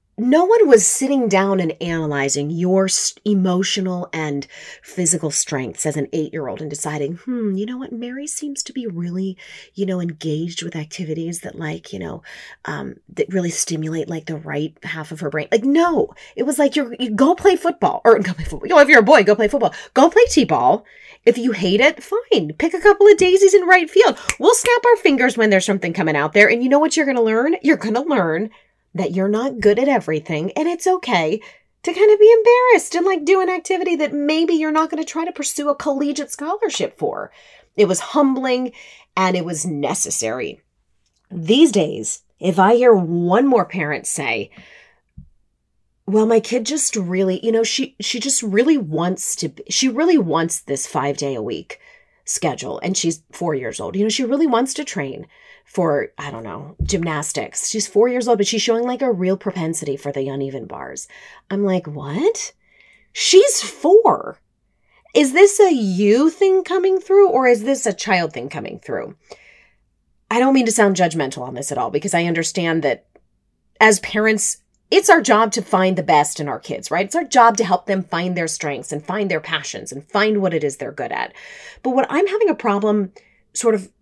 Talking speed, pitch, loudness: 205 wpm, 220 Hz, -17 LUFS